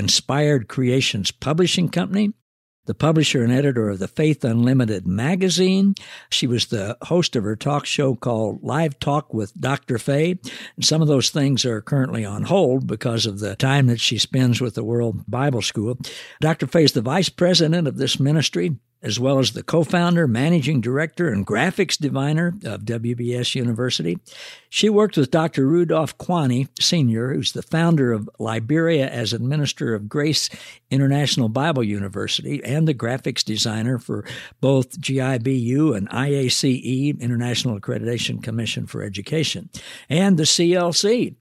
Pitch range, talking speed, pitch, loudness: 120-155 Hz, 155 wpm, 135 Hz, -20 LUFS